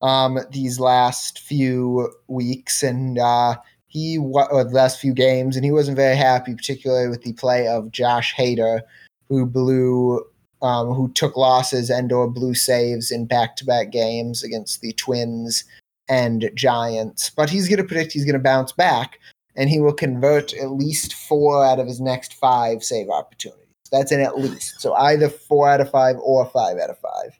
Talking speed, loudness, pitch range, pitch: 180 wpm, -19 LUFS, 120-135 Hz, 130 Hz